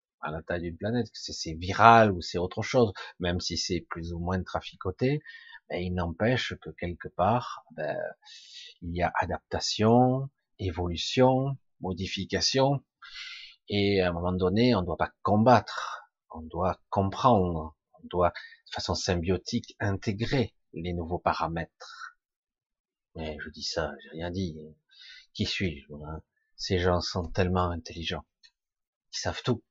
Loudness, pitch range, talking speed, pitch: -28 LUFS, 85-115 Hz, 140 wpm, 95 Hz